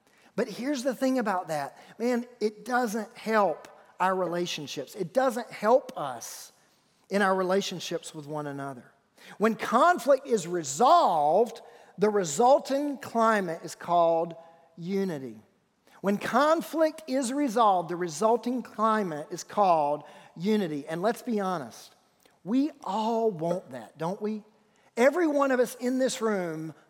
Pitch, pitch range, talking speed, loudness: 210 Hz, 175-245 Hz, 130 wpm, -27 LUFS